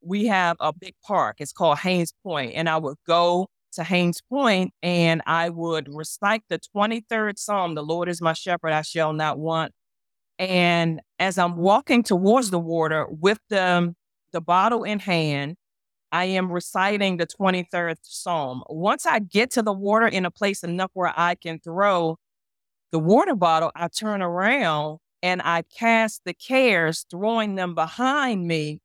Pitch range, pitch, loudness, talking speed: 165-205 Hz, 175 Hz, -23 LUFS, 165 wpm